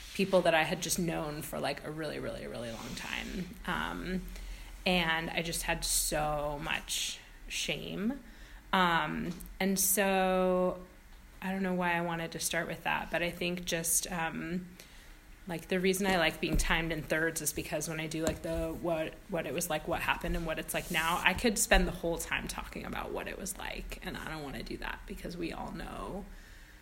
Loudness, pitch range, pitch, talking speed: -33 LUFS, 160-185 Hz, 170 Hz, 205 wpm